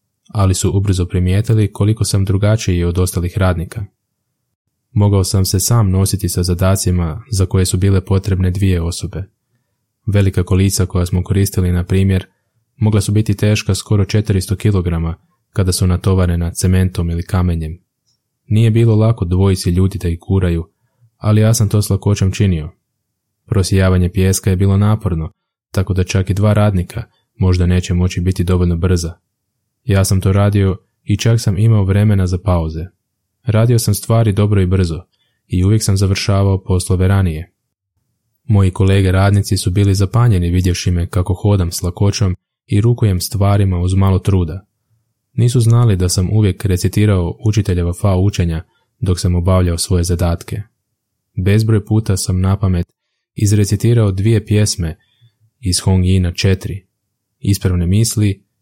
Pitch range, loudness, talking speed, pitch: 90-110 Hz, -15 LUFS, 145 wpm, 100 Hz